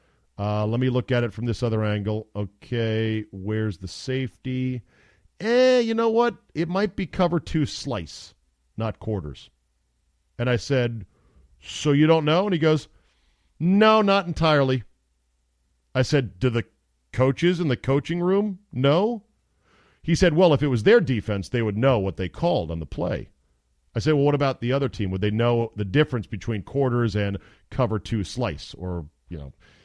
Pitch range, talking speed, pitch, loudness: 95-145 Hz, 175 wpm, 115 Hz, -23 LUFS